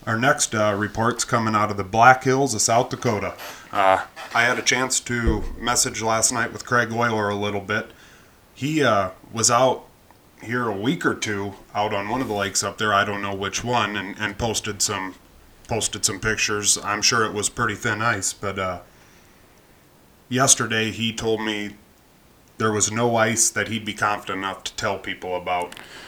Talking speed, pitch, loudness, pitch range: 190 wpm, 105 Hz, -21 LUFS, 100-115 Hz